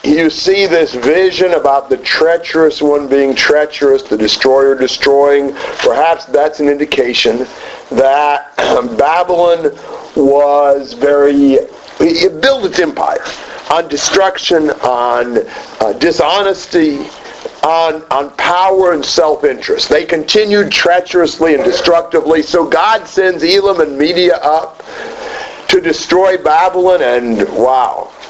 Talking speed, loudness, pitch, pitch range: 110 wpm, -11 LUFS, 165 Hz, 145-190 Hz